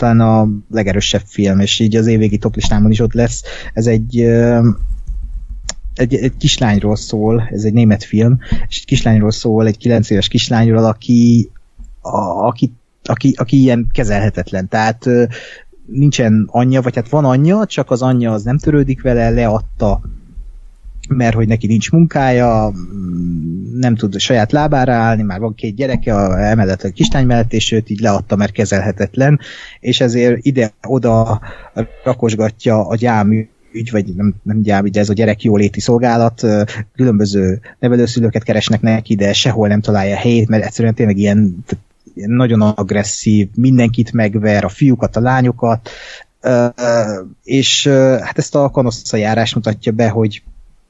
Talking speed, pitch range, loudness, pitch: 150 wpm, 105-120 Hz, -13 LUFS, 115 Hz